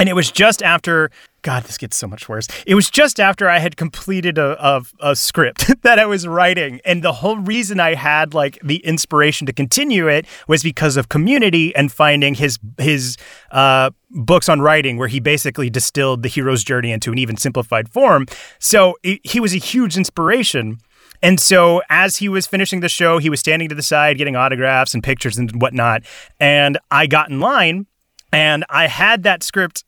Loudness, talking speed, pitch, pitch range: -14 LUFS, 200 wpm, 150 Hz, 135-180 Hz